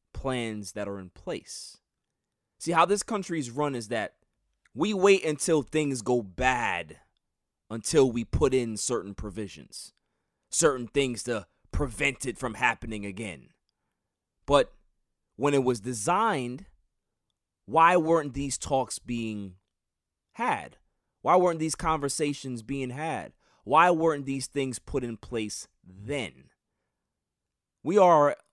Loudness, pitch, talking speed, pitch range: -27 LUFS, 125 Hz, 125 wpm, 110-145 Hz